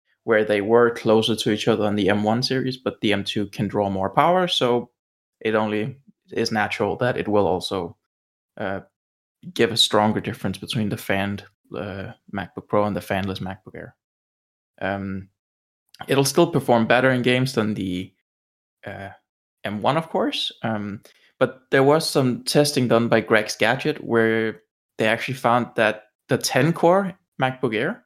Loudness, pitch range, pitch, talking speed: -21 LUFS, 100-130 Hz, 110 Hz, 165 wpm